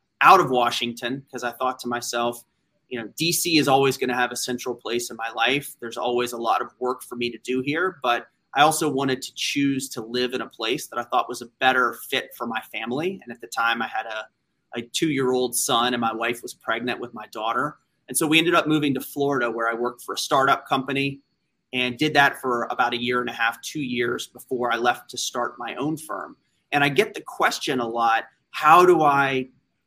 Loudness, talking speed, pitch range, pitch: -23 LUFS, 240 wpm, 120-140 Hz, 125 Hz